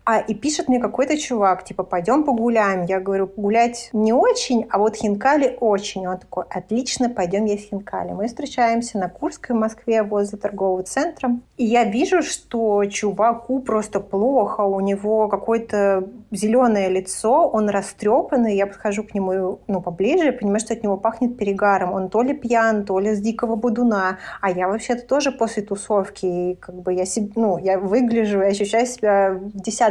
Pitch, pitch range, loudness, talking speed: 215 Hz, 195-235 Hz, -20 LUFS, 175 wpm